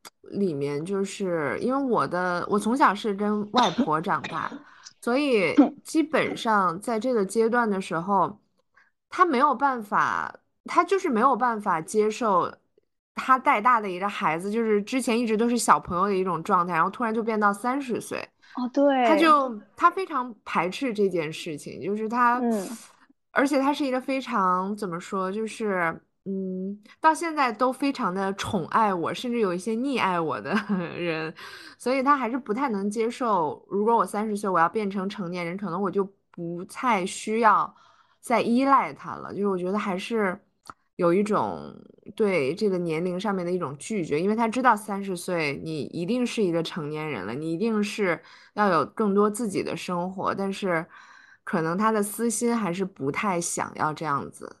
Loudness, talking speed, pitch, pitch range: -25 LUFS, 255 characters per minute, 210 Hz, 185-240 Hz